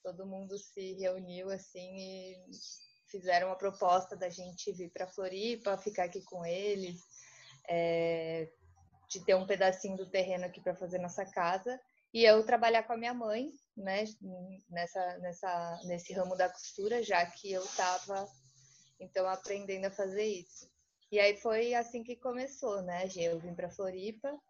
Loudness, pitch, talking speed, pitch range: -35 LUFS, 190 Hz, 155 wpm, 180-205 Hz